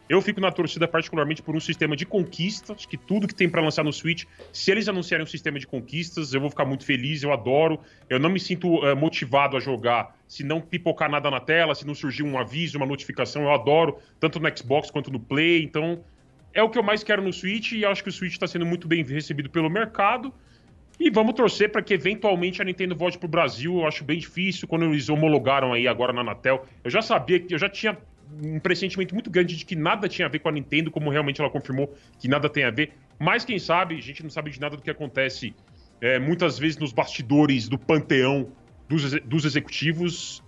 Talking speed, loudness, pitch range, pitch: 230 wpm, -24 LUFS, 145-180 Hz, 160 Hz